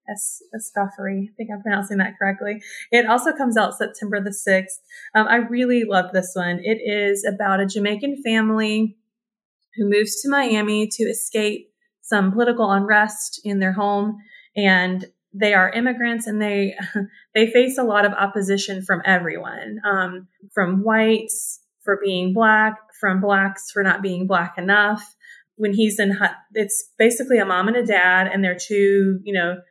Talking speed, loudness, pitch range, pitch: 165 wpm, -20 LUFS, 195-220 Hz, 205 Hz